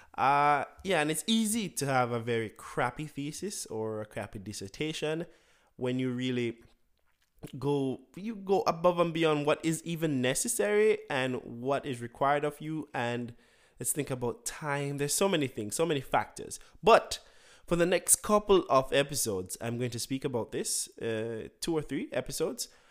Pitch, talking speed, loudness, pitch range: 140 Hz, 170 wpm, -30 LUFS, 120-165 Hz